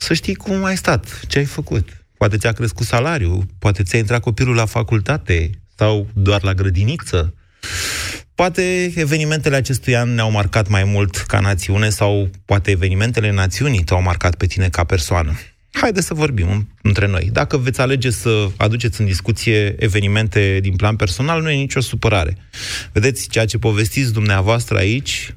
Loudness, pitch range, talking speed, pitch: -17 LUFS, 95-120 Hz, 160 wpm, 105 Hz